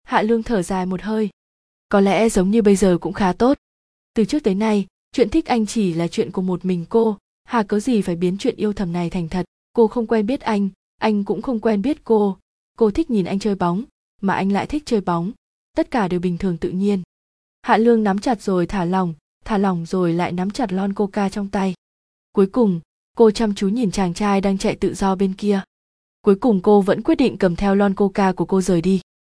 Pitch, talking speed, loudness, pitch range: 200 Hz, 235 wpm, -20 LUFS, 180-220 Hz